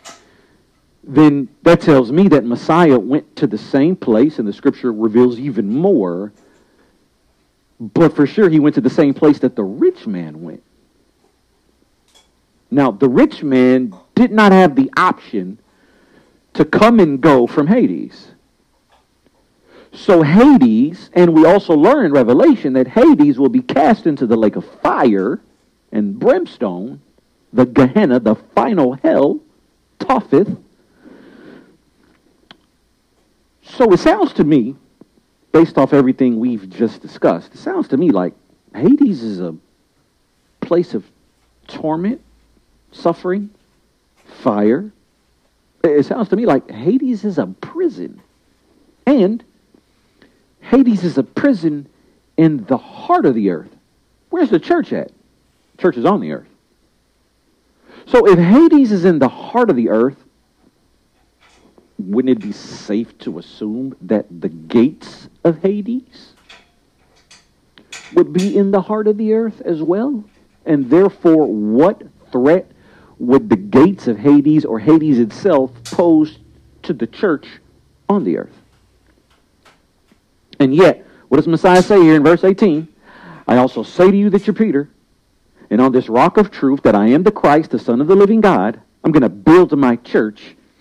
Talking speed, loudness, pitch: 145 wpm, -14 LUFS, 165 Hz